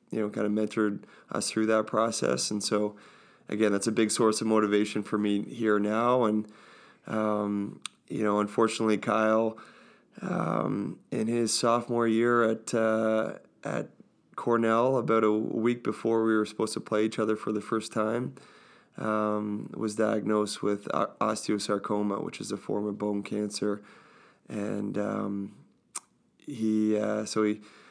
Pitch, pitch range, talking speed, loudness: 110 Hz, 105-110 Hz, 150 wpm, -28 LUFS